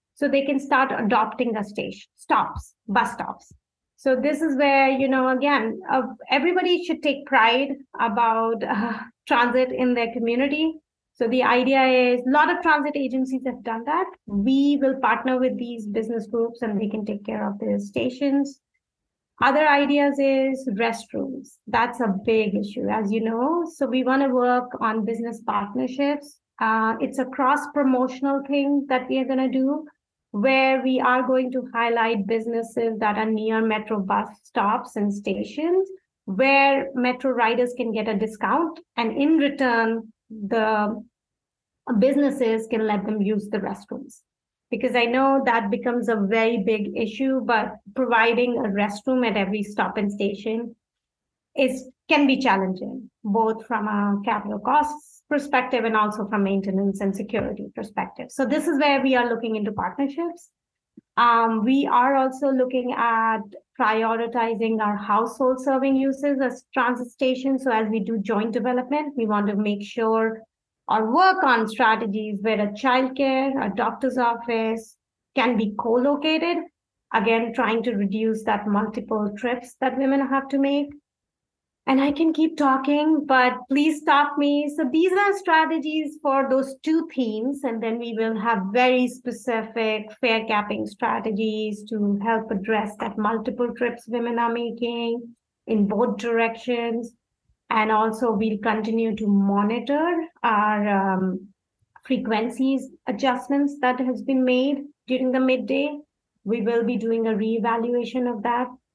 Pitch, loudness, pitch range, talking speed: 240 Hz, -23 LUFS, 225-270 Hz, 155 wpm